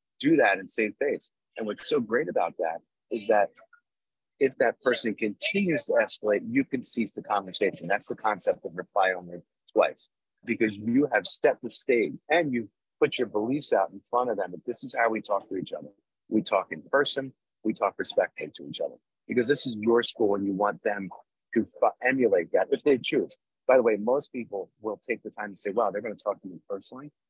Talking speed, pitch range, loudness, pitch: 220 wpm, 105-175 Hz, -27 LUFS, 120 Hz